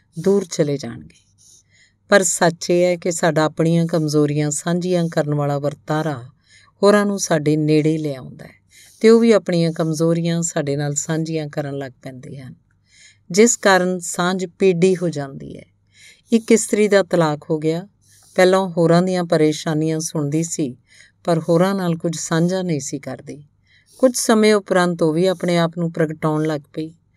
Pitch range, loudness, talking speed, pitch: 150-180 Hz, -18 LUFS, 155 wpm, 165 Hz